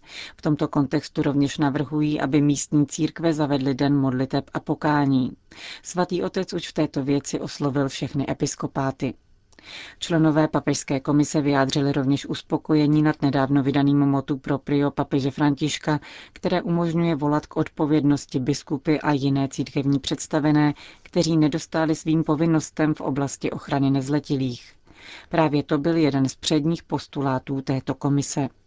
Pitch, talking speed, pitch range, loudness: 145 Hz, 130 wpm, 140-155 Hz, -23 LUFS